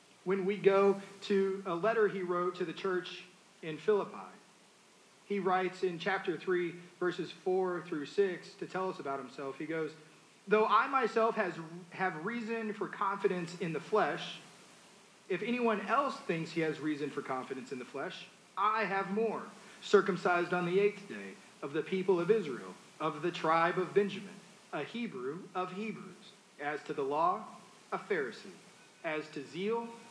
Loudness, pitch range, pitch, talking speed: -34 LUFS, 175-205 Hz, 190 Hz, 165 wpm